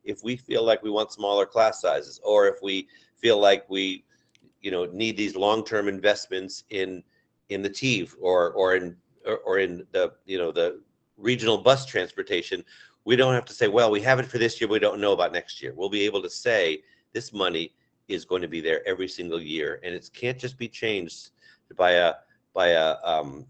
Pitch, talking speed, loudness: 125 Hz, 210 wpm, -25 LUFS